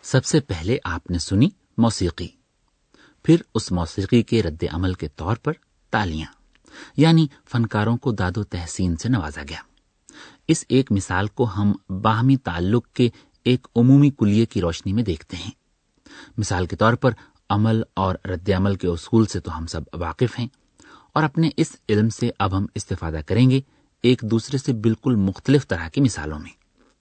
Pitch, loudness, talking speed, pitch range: 110 Hz, -22 LUFS, 170 wpm, 90-125 Hz